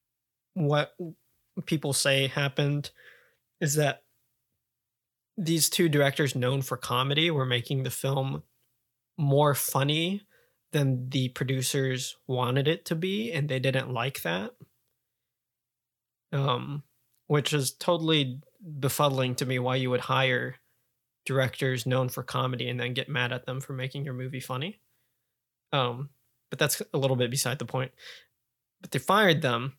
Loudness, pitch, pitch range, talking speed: -28 LUFS, 130 Hz, 125-145 Hz, 140 wpm